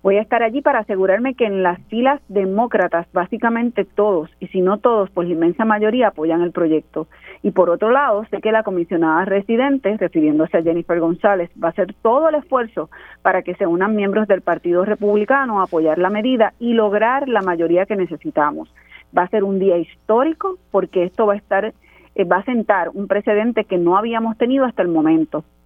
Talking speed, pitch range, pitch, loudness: 195 wpm, 175-225 Hz, 200 Hz, -18 LUFS